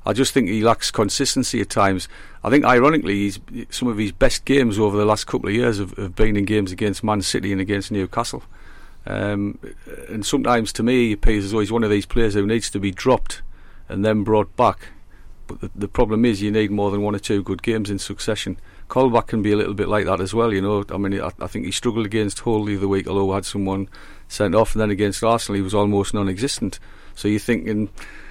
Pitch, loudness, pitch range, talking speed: 105 Hz, -20 LUFS, 100-115 Hz, 240 wpm